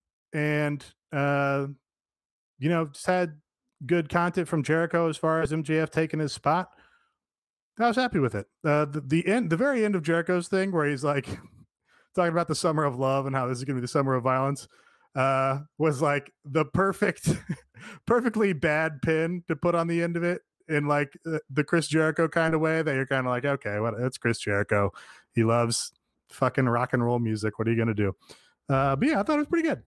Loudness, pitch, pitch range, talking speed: -26 LUFS, 150 Hz, 135-170 Hz, 215 wpm